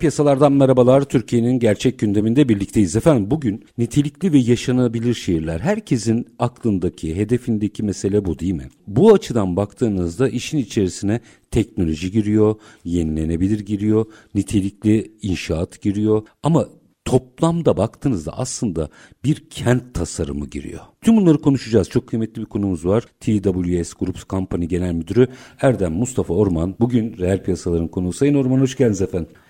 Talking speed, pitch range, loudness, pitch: 130 wpm, 95-125 Hz, -19 LUFS, 110 Hz